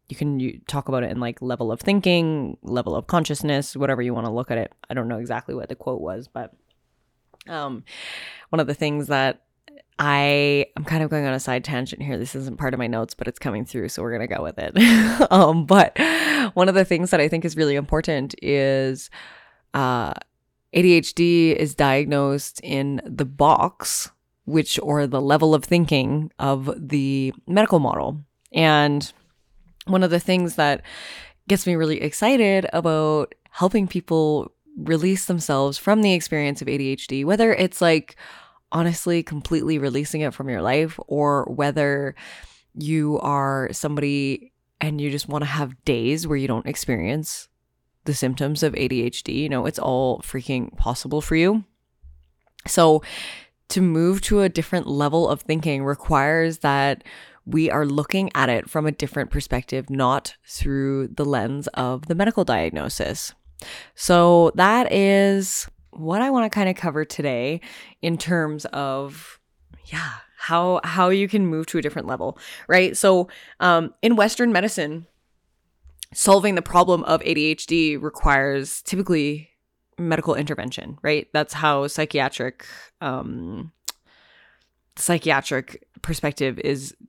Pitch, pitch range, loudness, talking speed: 150 Hz, 135-170 Hz, -21 LUFS, 155 wpm